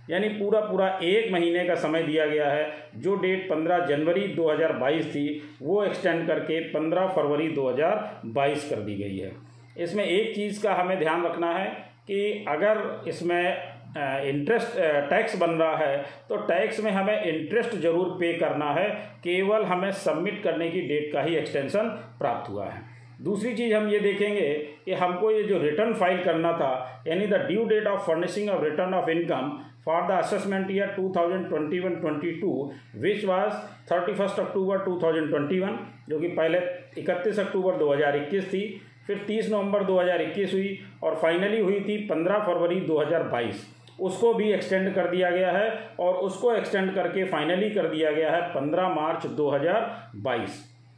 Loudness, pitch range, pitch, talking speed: -26 LUFS, 155-195 Hz, 180 Hz, 160 wpm